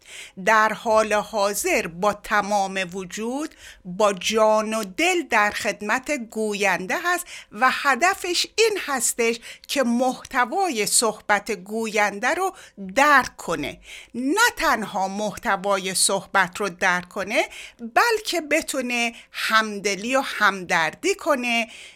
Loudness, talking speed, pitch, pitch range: -22 LUFS, 105 wpm, 220 Hz, 205-280 Hz